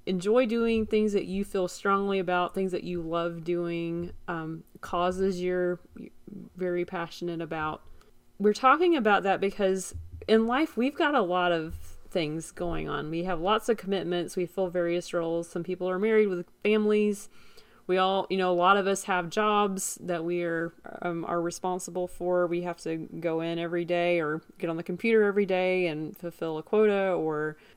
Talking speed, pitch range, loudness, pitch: 185 wpm, 170-200 Hz, -28 LUFS, 180 Hz